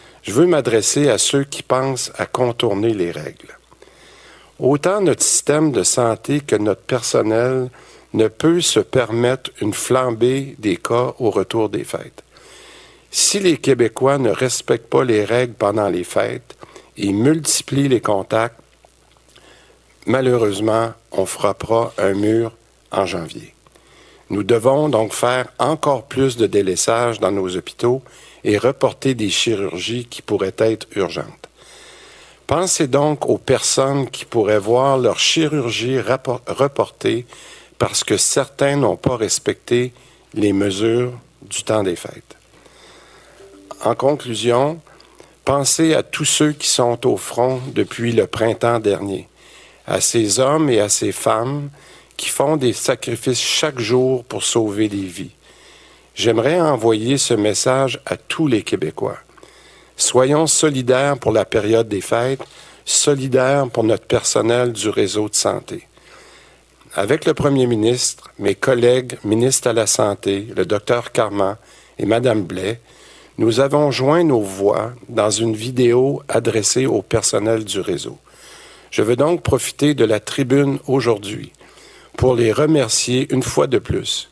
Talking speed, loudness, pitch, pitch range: 135 wpm, -17 LUFS, 125 Hz, 110-135 Hz